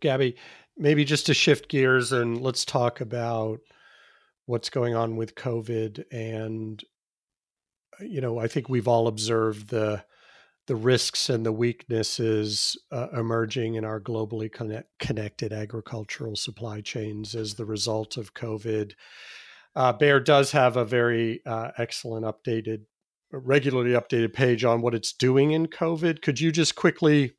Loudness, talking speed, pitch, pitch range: -26 LUFS, 145 wpm, 120 Hz, 110-135 Hz